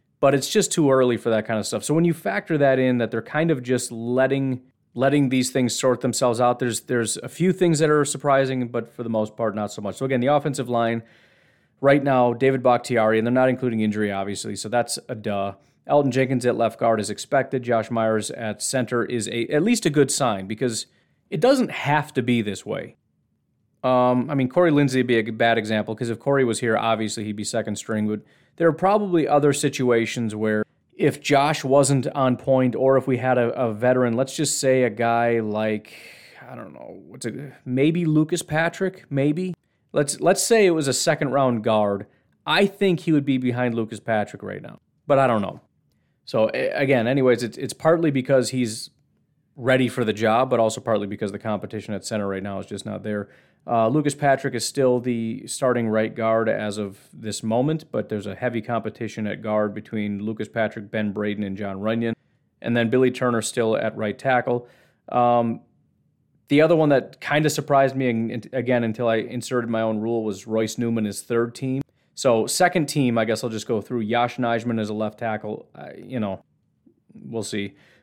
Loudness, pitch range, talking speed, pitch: -22 LUFS, 110-135 Hz, 210 wpm, 120 Hz